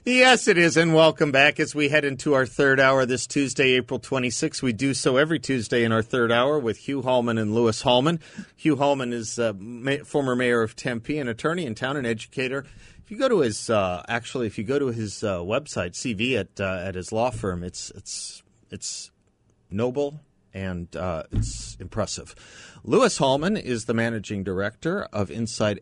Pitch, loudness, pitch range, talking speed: 120 Hz, -23 LUFS, 110-140 Hz, 200 wpm